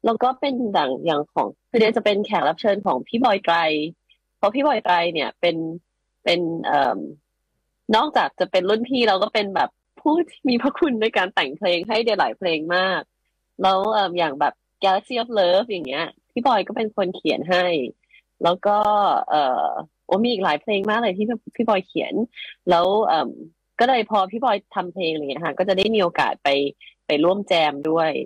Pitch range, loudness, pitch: 170-225 Hz, -21 LUFS, 195 Hz